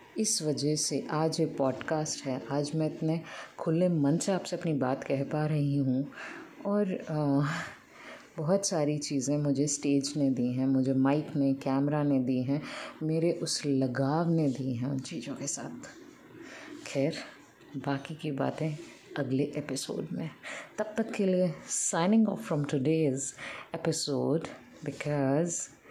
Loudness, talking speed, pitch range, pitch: -30 LUFS, 150 wpm, 140-165 Hz, 150 Hz